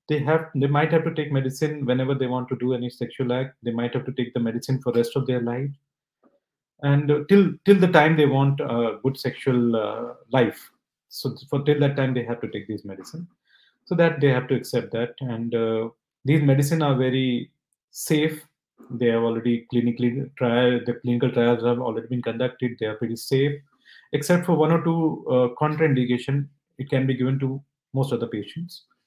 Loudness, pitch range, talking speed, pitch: -23 LUFS, 120-150 Hz, 205 wpm, 130 Hz